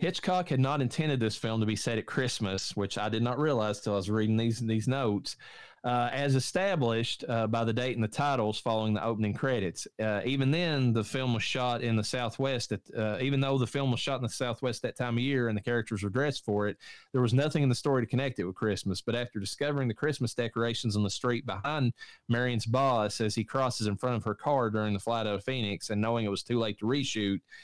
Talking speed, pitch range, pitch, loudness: 245 wpm, 110-130 Hz, 120 Hz, -30 LUFS